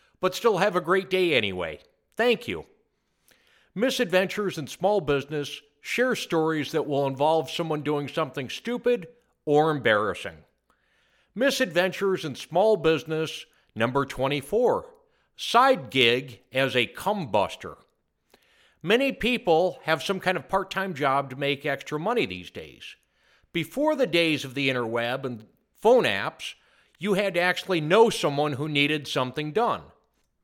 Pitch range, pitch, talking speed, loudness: 140-200 Hz, 160 Hz, 135 wpm, -25 LUFS